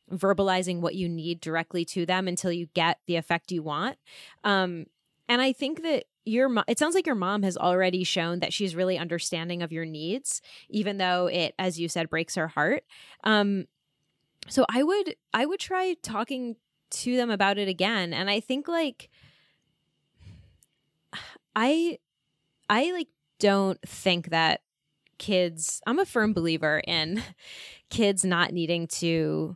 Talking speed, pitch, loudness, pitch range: 160 wpm, 180 Hz, -27 LUFS, 165-215 Hz